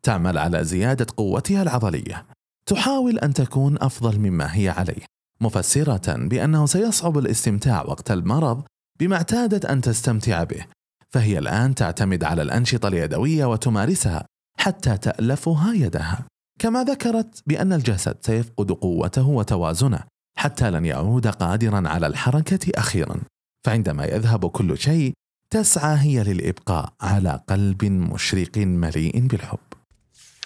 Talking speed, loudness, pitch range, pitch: 115 wpm, -21 LUFS, 100-150 Hz, 120 Hz